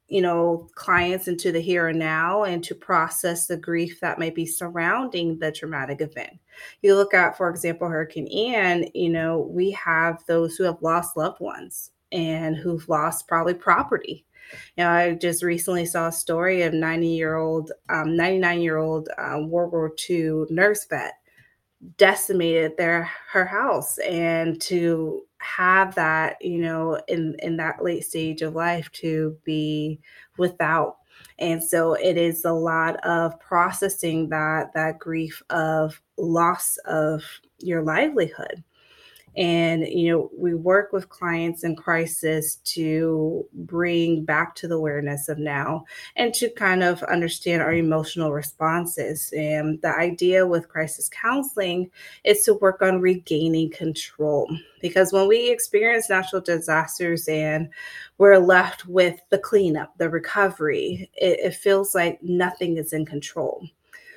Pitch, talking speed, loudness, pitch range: 170 Hz, 150 wpm, -22 LUFS, 160-180 Hz